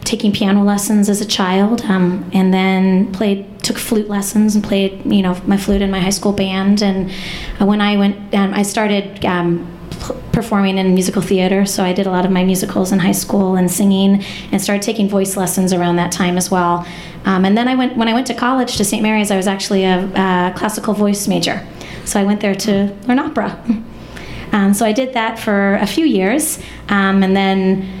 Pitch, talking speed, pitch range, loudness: 200 Hz, 210 wpm, 190-210 Hz, -15 LUFS